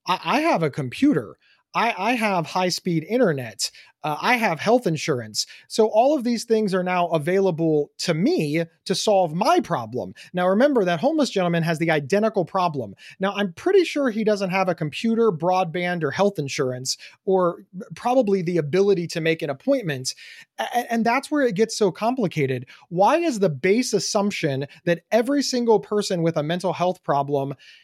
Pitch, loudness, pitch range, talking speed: 190 Hz, -22 LUFS, 165-225 Hz, 175 wpm